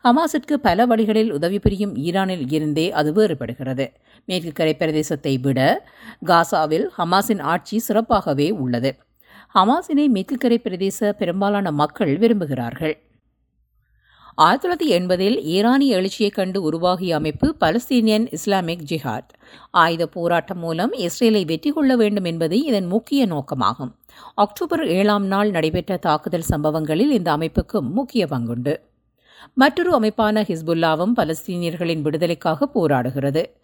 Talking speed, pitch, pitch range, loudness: 110 wpm, 185 Hz, 155-220 Hz, -20 LUFS